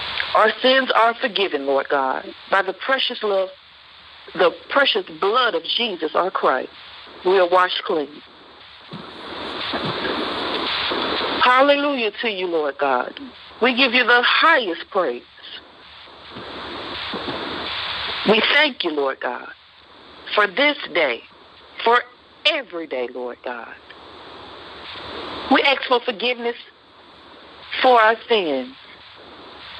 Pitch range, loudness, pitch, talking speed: 195-270 Hz, -19 LUFS, 240 Hz, 105 wpm